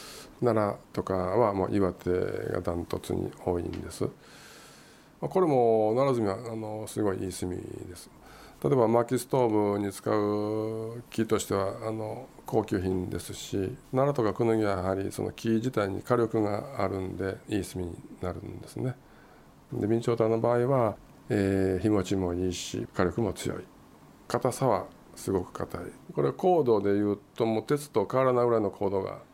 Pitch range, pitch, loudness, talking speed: 95-120 Hz, 105 Hz, -29 LUFS, 305 characters per minute